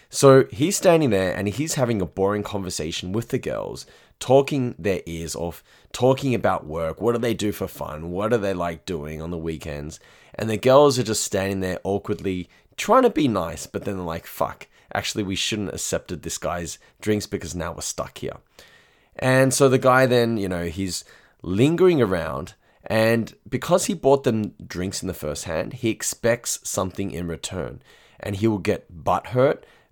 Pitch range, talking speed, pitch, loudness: 90-125 Hz, 190 wpm, 100 Hz, -23 LUFS